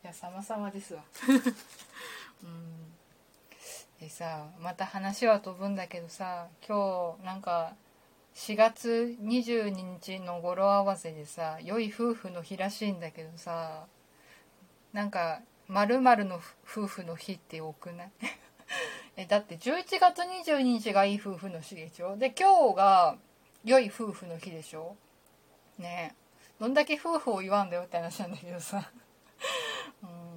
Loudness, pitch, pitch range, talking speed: -30 LUFS, 190 Hz, 170-220 Hz, 235 characters per minute